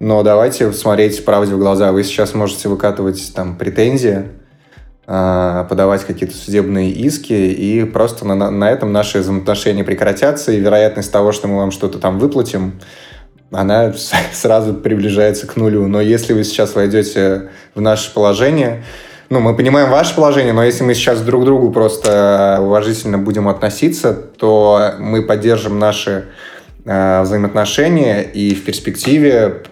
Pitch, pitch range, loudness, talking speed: 105 Hz, 100-110 Hz, -13 LUFS, 140 wpm